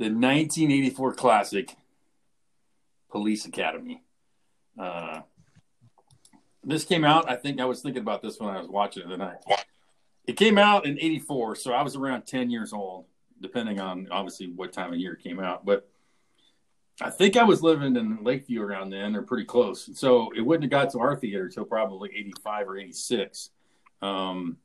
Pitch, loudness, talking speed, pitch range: 130 Hz, -26 LUFS, 175 wpm, 100-160 Hz